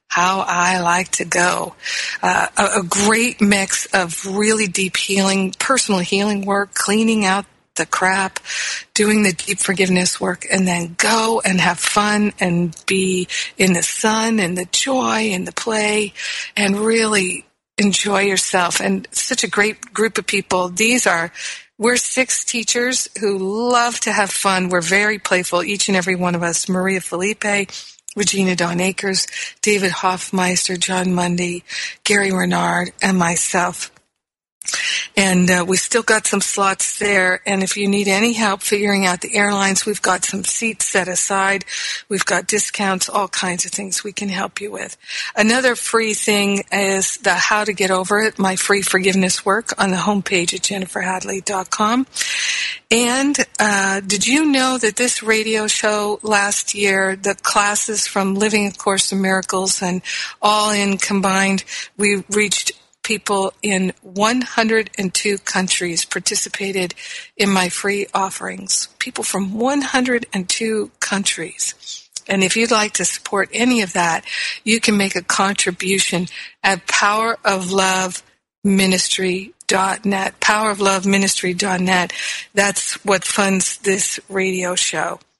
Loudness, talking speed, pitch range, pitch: -17 LUFS, 140 wpm, 185-210 Hz, 195 Hz